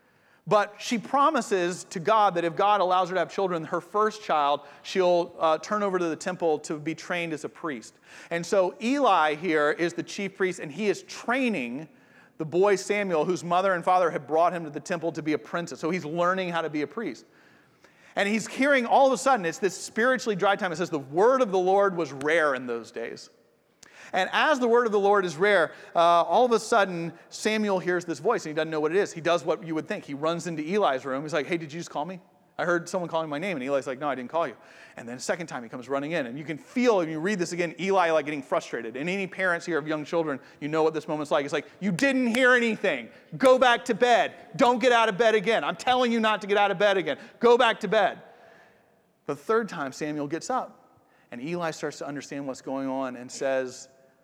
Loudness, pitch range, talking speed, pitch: -26 LUFS, 155-210 Hz, 255 wpm, 180 Hz